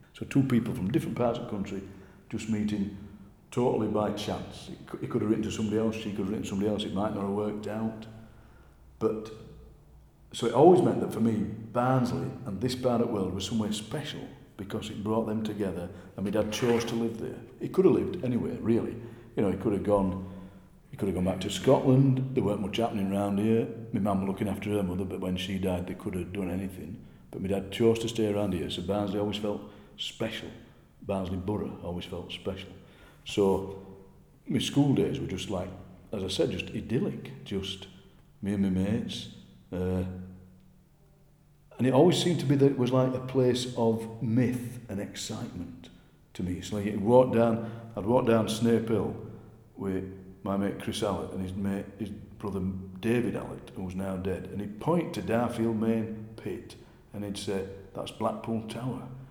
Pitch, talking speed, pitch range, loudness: 105 Hz, 195 wpm, 95-115 Hz, -30 LUFS